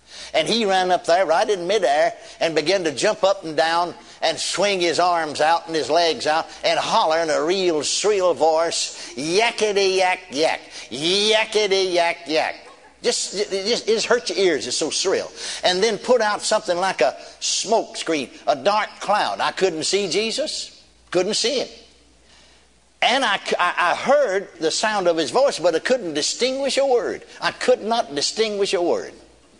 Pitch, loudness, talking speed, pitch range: 200 Hz, -20 LUFS, 180 wpm, 170-240 Hz